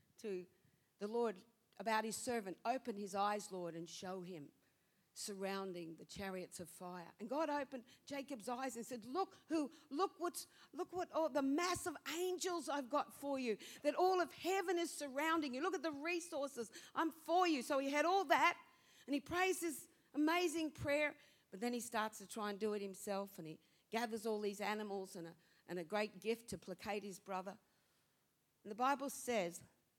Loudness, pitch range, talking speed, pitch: -42 LUFS, 200-315 Hz, 190 wpm, 240 Hz